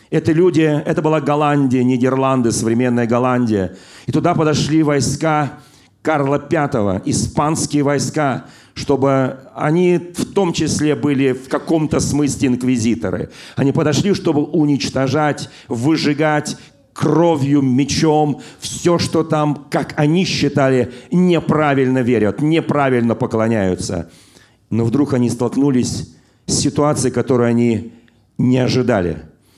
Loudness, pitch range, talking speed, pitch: -16 LUFS, 125-150 Hz, 110 wpm, 140 Hz